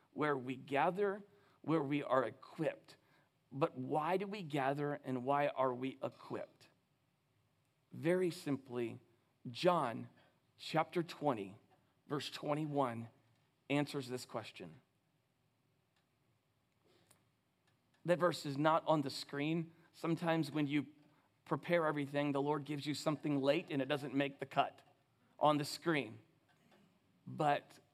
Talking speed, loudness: 120 wpm, -38 LUFS